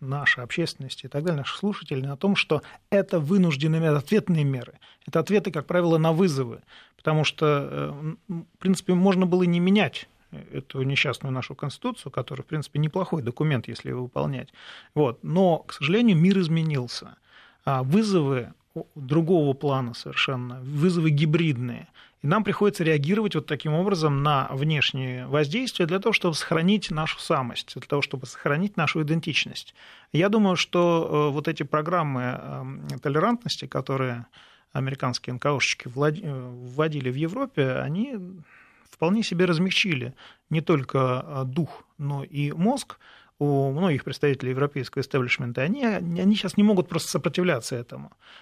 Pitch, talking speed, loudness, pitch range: 155 Hz, 135 wpm, -25 LUFS, 135-180 Hz